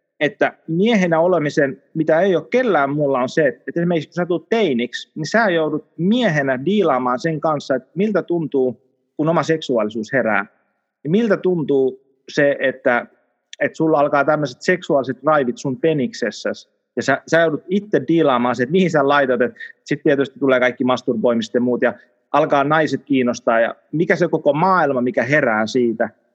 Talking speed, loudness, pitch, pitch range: 165 wpm, -18 LUFS, 145 Hz, 130-165 Hz